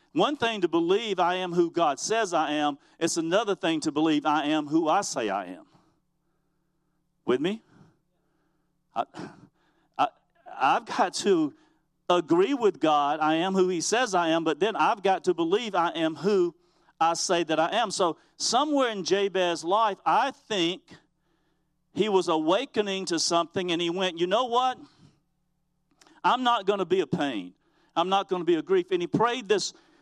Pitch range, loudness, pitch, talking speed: 165-225 Hz, -26 LUFS, 175 Hz, 180 wpm